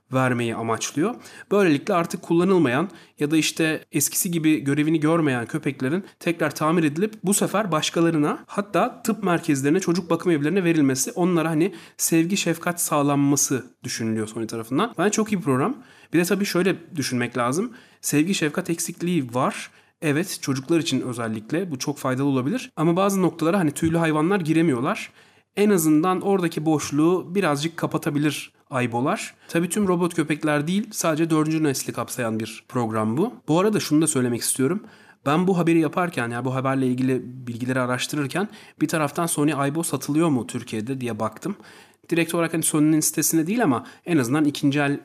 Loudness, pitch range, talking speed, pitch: -23 LUFS, 135-170 Hz, 160 wpm, 155 Hz